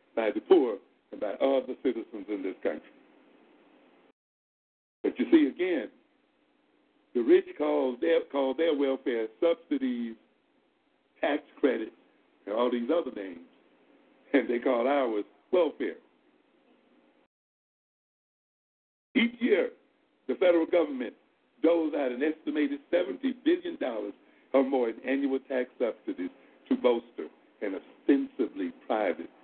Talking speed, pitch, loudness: 115 wpm, 275 Hz, -29 LUFS